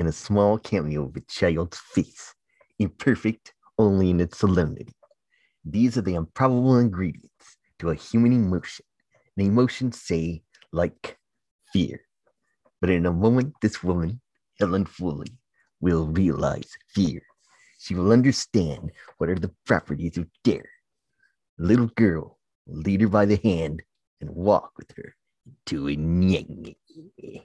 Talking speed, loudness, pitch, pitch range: 140 wpm, -24 LUFS, 100 Hz, 85-115 Hz